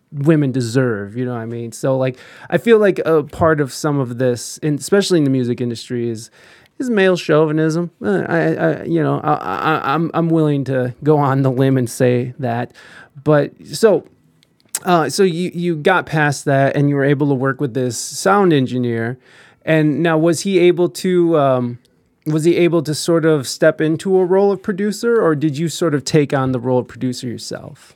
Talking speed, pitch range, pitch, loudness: 200 wpm, 130-170 Hz, 150 Hz, -17 LUFS